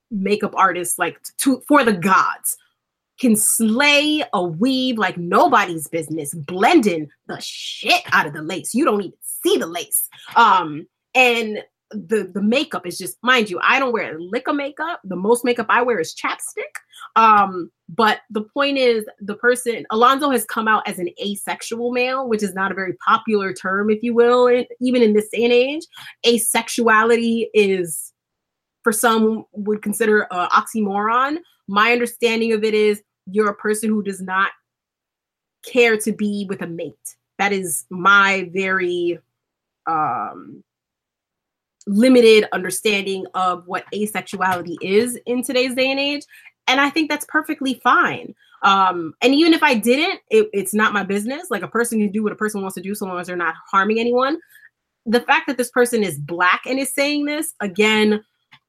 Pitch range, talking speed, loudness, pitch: 190-250 Hz, 175 wpm, -18 LUFS, 220 Hz